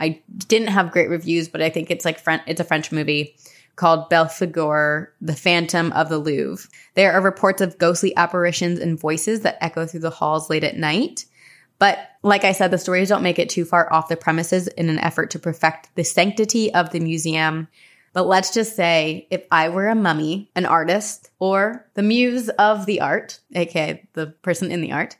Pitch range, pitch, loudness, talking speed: 160-195 Hz, 170 Hz, -20 LUFS, 200 wpm